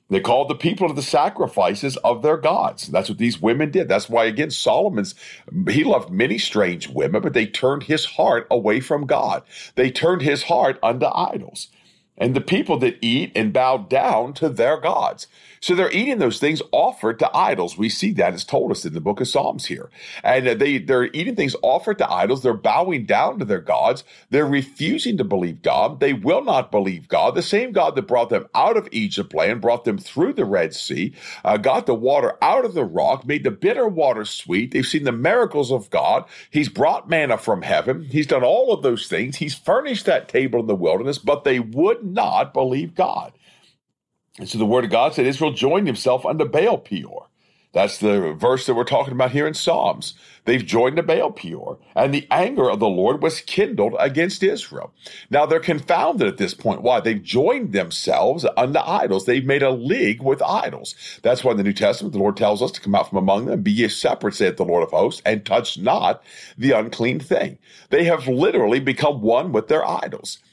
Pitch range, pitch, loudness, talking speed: 120-155 Hz, 140 Hz, -20 LUFS, 210 wpm